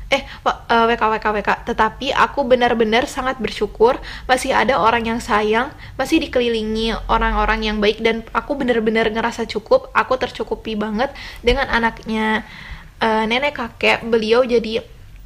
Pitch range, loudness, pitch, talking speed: 220-255 Hz, -18 LUFS, 230 Hz, 140 wpm